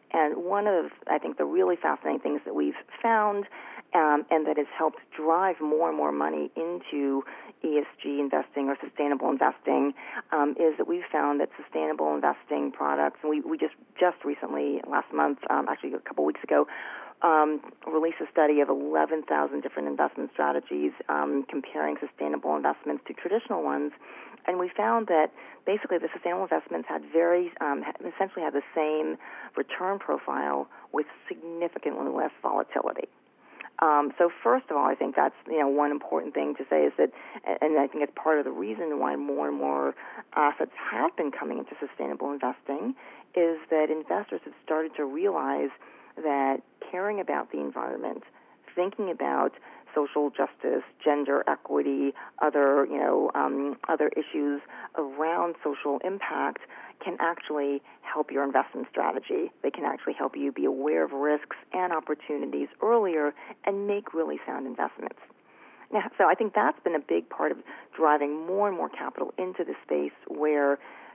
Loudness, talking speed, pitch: -28 LUFS, 165 wpm, 145 Hz